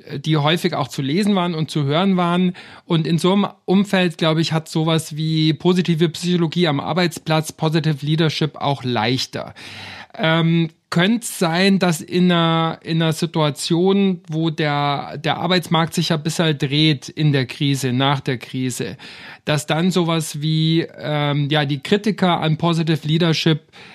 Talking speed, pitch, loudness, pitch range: 160 wpm, 165 Hz, -19 LUFS, 150-175 Hz